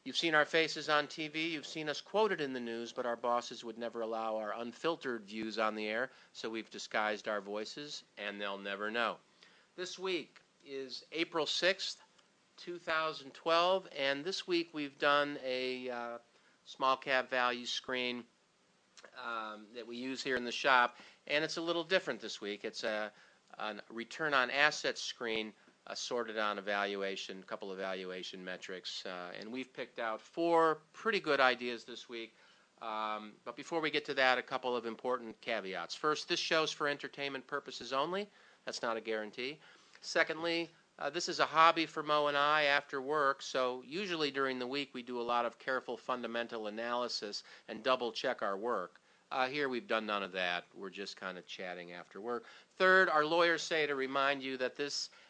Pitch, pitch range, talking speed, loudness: 130 Hz, 115-155 Hz, 180 wpm, -35 LUFS